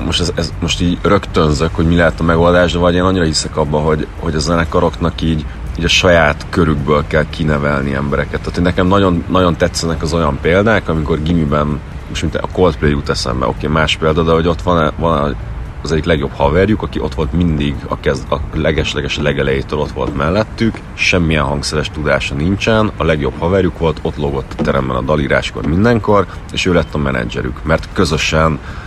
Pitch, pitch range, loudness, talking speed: 80 Hz, 75-85 Hz, -14 LUFS, 195 wpm